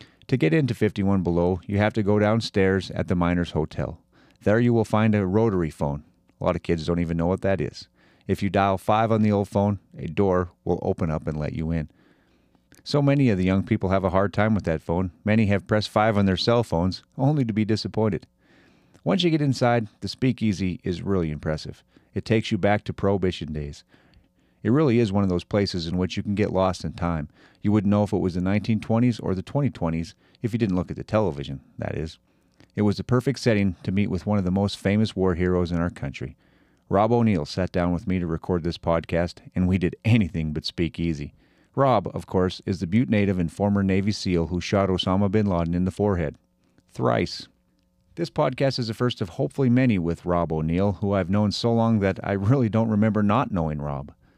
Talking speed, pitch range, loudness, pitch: 225 wpm, 85-110 Hz, -24 LUFS, 95 Hz